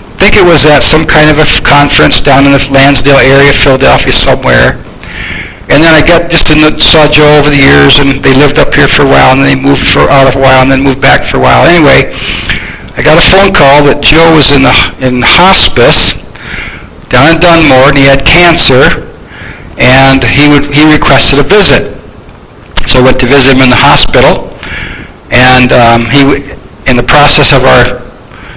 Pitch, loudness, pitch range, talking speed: 140 Hz, -3 LUFS, 125-150 Hz, 210 wpm